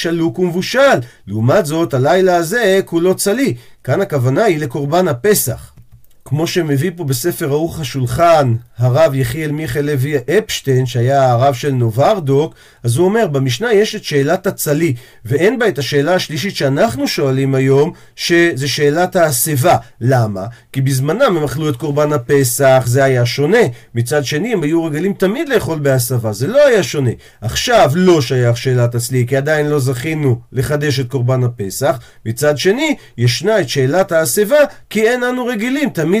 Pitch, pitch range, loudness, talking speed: 145 Hz, 130-170 Hz, -14 LUFS, 155 wpm